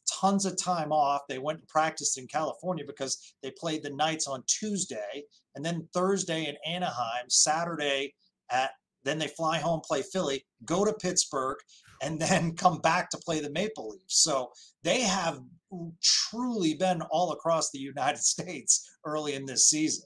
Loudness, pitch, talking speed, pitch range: -29 LUFS, 160 Hz, 170 wpm, 145-180 Hz